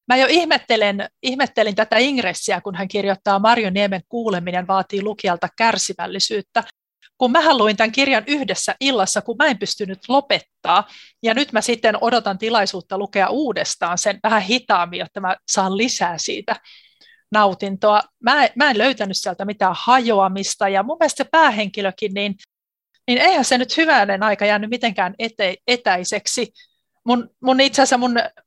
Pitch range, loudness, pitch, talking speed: 200-255 Hz, -18 LUFS, 215 Hz, 150 wpm